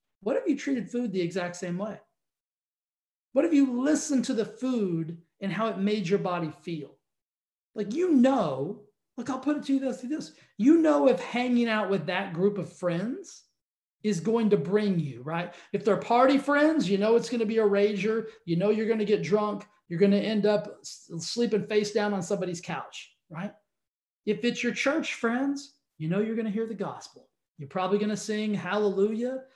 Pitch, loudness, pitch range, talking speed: 210 Hz, -27 LUFS, 190-245 Hz, 205 wpm